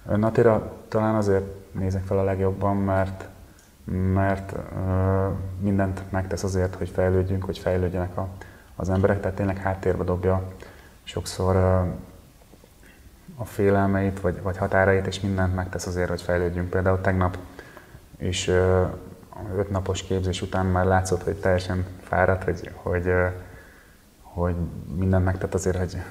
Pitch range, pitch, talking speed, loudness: 90-95 Hz, 95 Hz, 120 wpm, -25 LUFS